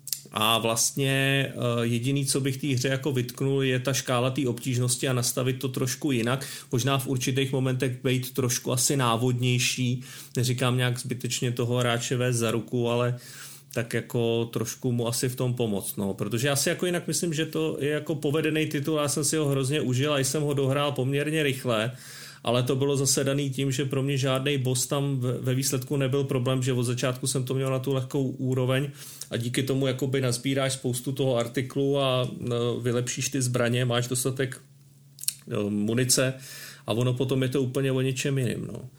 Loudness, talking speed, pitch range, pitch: -26 LUFS, 185 wpm, 125-140 Hz, 130 Hz